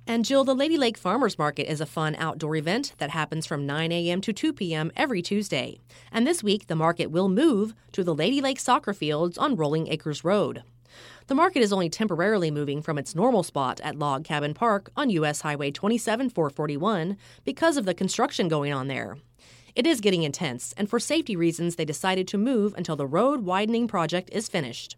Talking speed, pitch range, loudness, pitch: 200 wpm, 155-220 Hz, -26 LUFS, 175 Hz